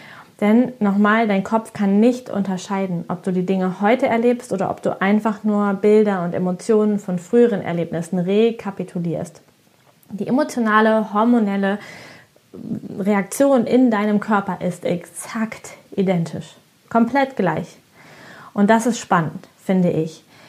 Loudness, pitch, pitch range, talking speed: -19 LUFS, 205 Hz, 185-225 Hz, 125 wpm